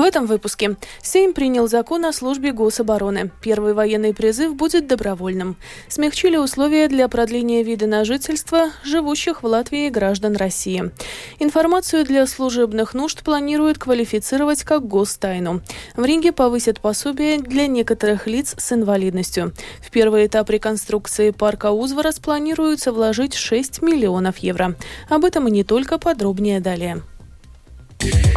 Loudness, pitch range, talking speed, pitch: -19 LUFS, 210-300 Hz, 130 wpm, 235 Hz